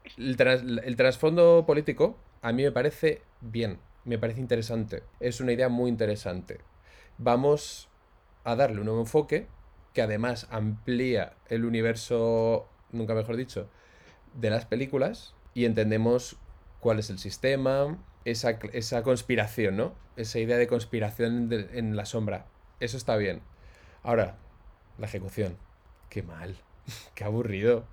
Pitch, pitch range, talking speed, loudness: 115 Hz, 105-125 Hz, 130 wpm, -28 LUFS